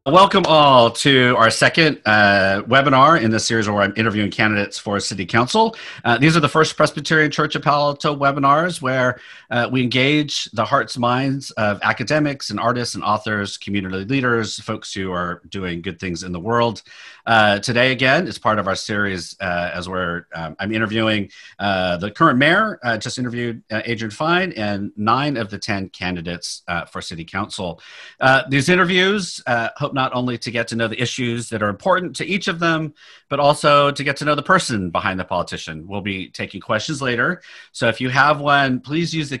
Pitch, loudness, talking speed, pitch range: 120 Hz, -18 LUFS, 205 wpm, 105-145 Hz